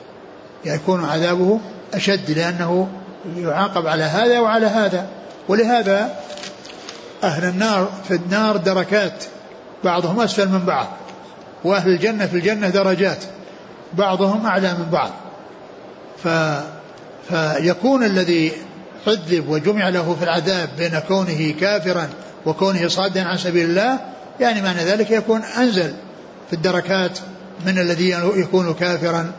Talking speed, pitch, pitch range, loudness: 110 wpm, 185 Hz, 175-200 Hz, -19 LUFS